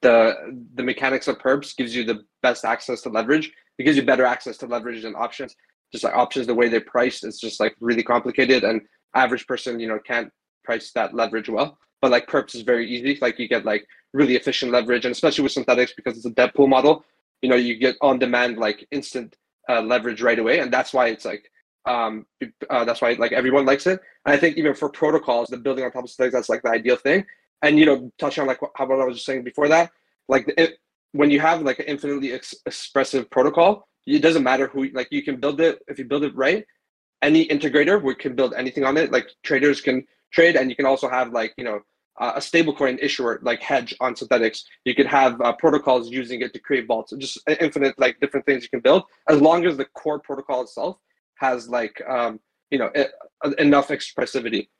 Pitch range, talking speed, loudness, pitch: 120-145 Hz, 230 wpm, -21 LUFS, 135 Hz